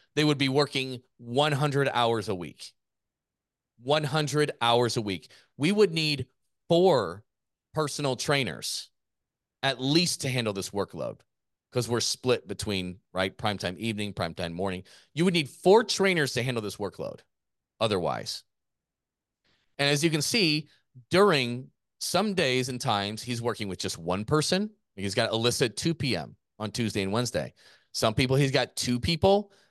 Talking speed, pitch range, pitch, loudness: 150 wpm, 110-150 Hz, 125 Hz, -27 LUFS